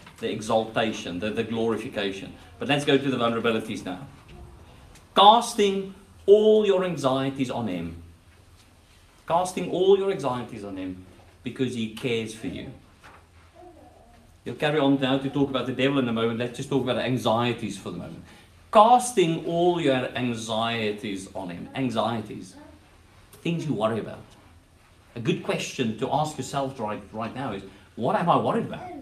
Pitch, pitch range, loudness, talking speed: 115 Hz, 100-140 Hz, -25 LUFS, 155 wpm